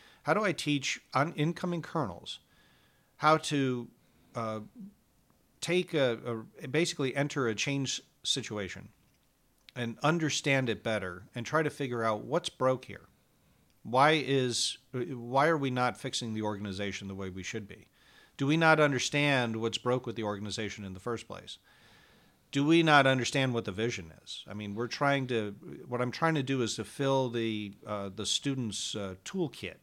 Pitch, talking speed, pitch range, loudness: 125 Hz, 170 wpm, 110-145 Hz, -31 LUFS